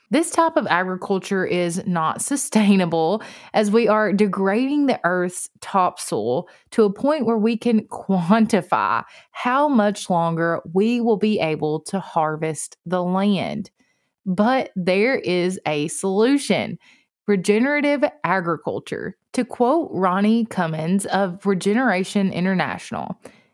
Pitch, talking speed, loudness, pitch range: 200 Hz, 115 wpm, -21 LUFS, 180-230 Hz